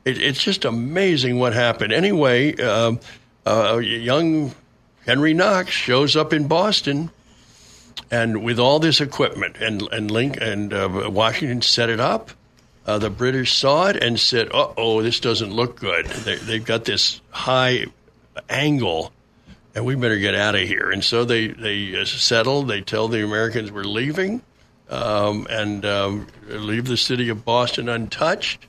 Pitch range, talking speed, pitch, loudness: 110-130 Hz, 160 wpm, 115 Hz, -20 LUFS